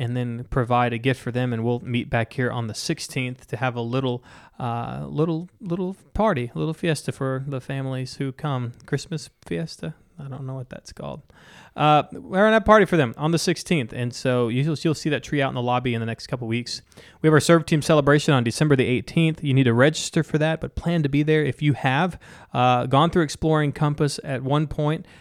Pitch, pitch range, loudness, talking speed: 135 Hz, 125-155 Hz, -22 LUFS, 230 wpm